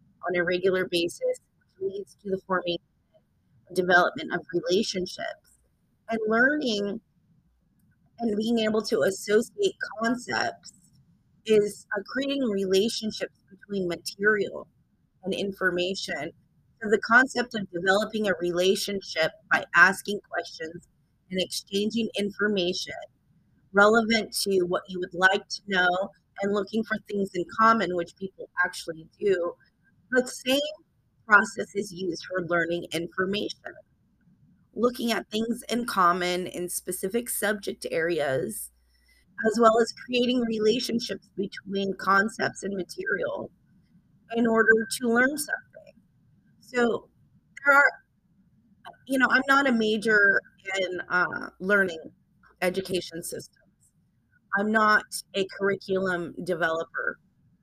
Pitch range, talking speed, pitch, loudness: 180-225 Hz, 115 wpm, 200 Hz, -26 LUFS